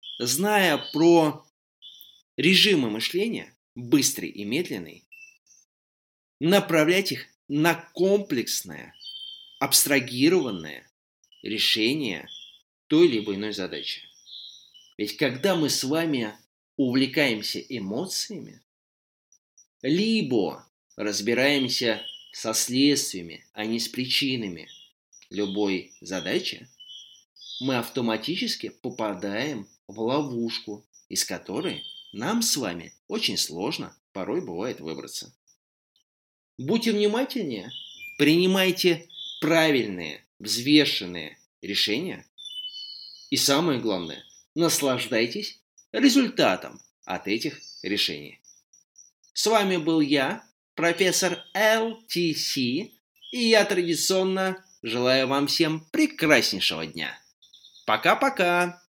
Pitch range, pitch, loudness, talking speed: 120-190 Hz, 155 Hz, -24 LUFS, 80 wpm